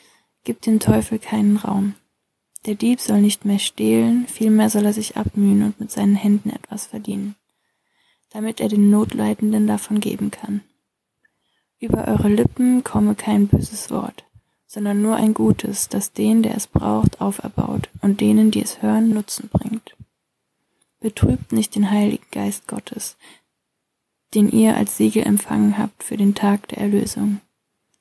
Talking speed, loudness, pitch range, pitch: 150 wpm, -19 LUFS, 205-220 Hz, 210 Hz